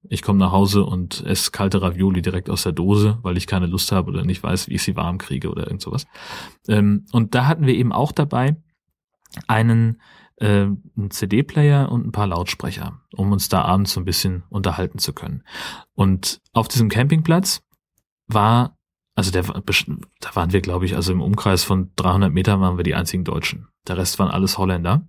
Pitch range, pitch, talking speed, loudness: 90-115 Hz, 100 Hz, 195 wpm, -20 LUFS